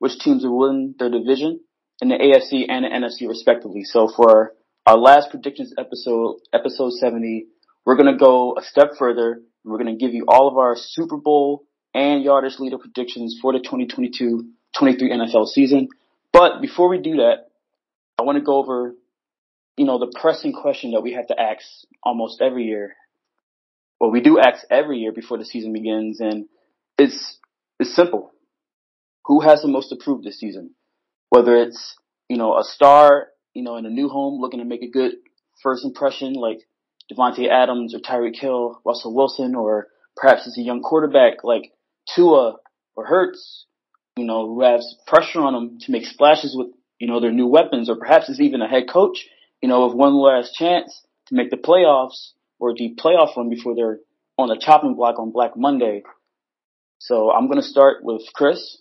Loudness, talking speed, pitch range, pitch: -17 LUFS, 190 wpm, 120-145 Hz, 130 Hz